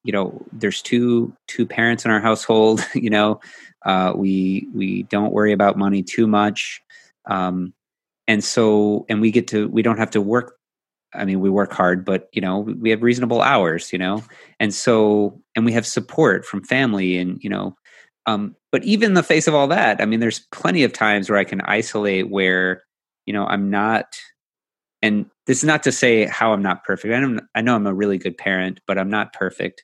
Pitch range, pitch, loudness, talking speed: 95-115 Hz, 105 Hz, -19 LUFS, 210 wpm